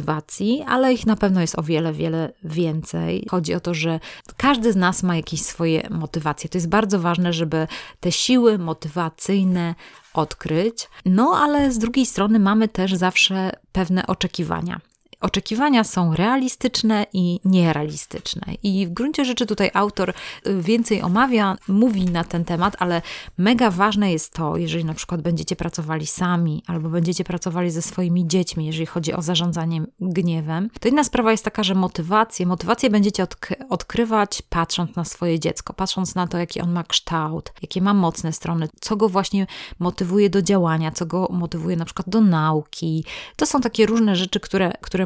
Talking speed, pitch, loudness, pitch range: 165 wpm, 185 Hz, -21 LUFS, 170-210 Hz